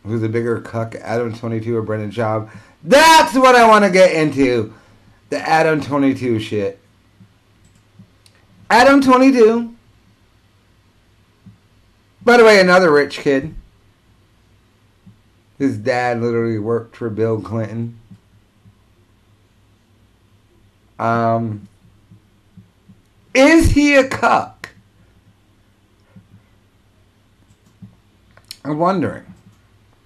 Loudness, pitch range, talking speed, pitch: -14 LUFS, 100-120 Hz, 90 wpm, 110 Hz